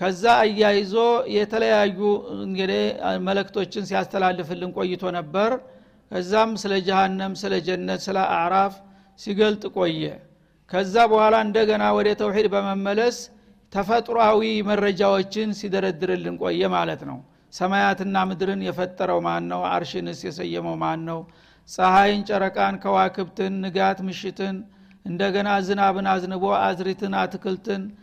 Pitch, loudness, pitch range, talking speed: 195 Hz, -22 LUFS, 185-205 Hz, 105 wpm